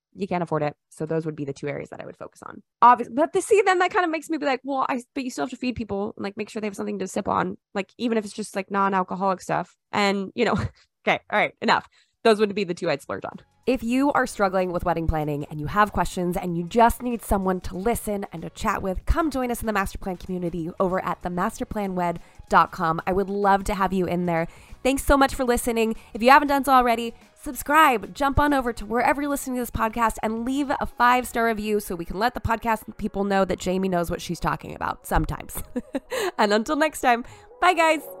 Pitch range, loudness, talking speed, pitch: 185-255 Hz, -24 LUFS, 255 wpm, 215 Hz